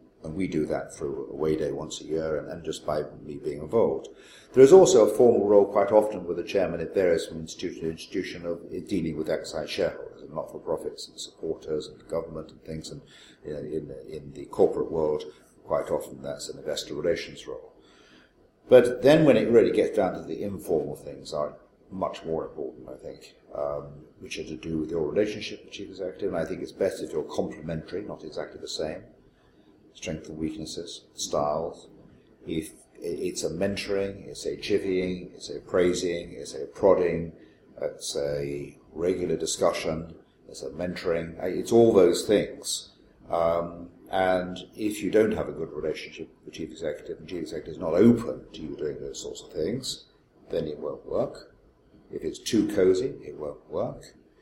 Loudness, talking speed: -27 LUFS, 185 wpm